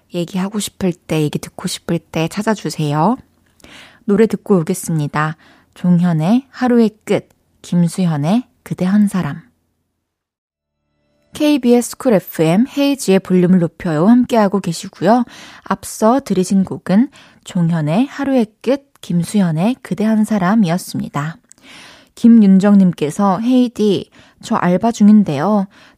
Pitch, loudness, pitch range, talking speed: 190 Hz, -15 LUFS, 170-225 Hz, 270 characters per minute